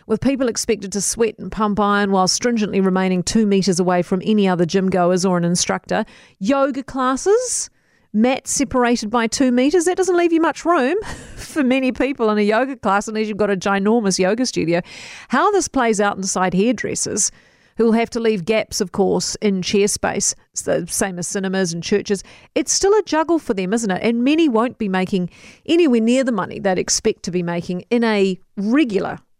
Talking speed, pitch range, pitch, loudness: 200 wpm, 190-255 Hz, 215 Hz, -18 LUFS